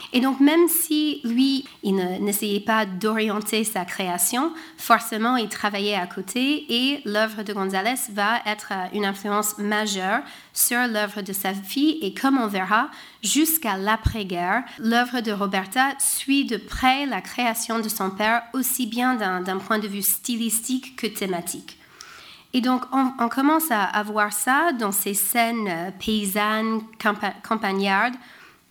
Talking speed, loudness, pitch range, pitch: 155 wpm, -23 LUFS, 205-250 Hz, 220 Hz